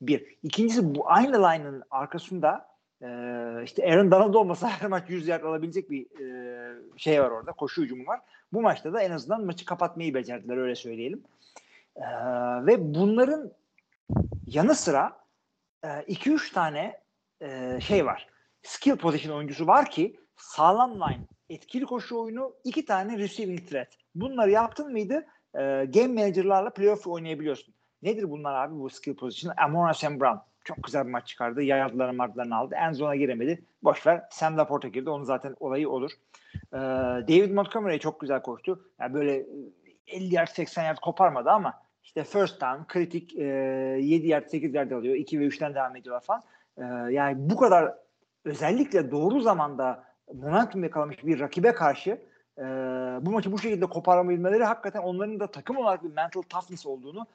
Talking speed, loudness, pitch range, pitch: 155 wpm, -27 LUFS, 135-195 Hz, 160 Hz